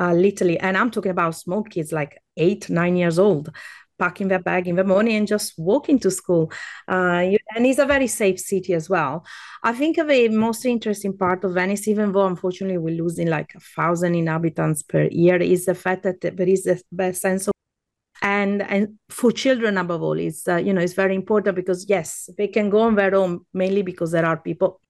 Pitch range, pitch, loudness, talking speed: 175-205 Hz, 190 Hz, -21 LUFS, 210 wpm